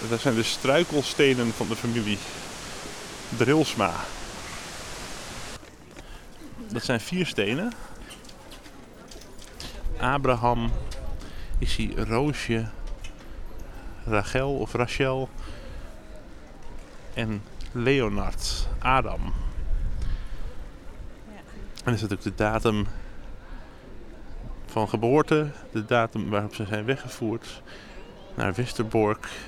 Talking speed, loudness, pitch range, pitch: 75 wpm, -27 LUFS, 100-125 Hz, 115 Hz